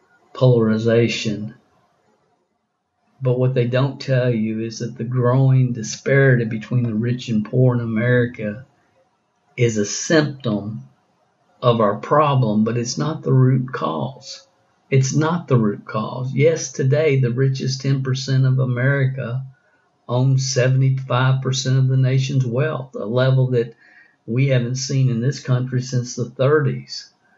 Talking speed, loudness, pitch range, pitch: 135 wpm, -19 LUFS, 120-135 Hz, 130 Hz